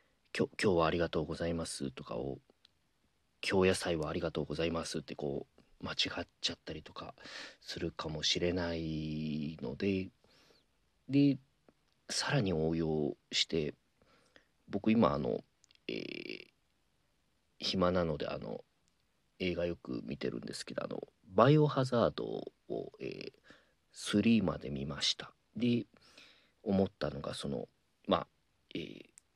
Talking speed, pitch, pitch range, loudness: 245 characters per minute, 85 Hz, 75-95 Hz, -35 LUFS